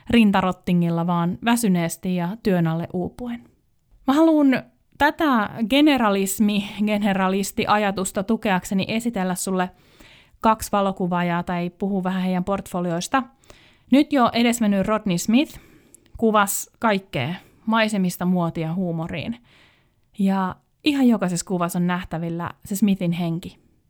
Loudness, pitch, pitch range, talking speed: -22 LUFS, 195 Hz, 180-225 Hz, 105 wpm